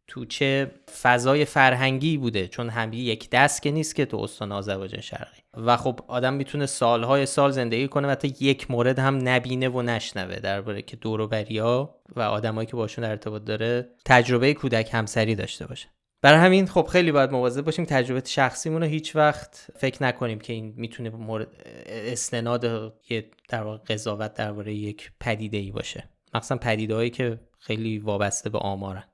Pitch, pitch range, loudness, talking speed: 120 Hz, 110-135 Hz, -24 LUFS, 170 wpm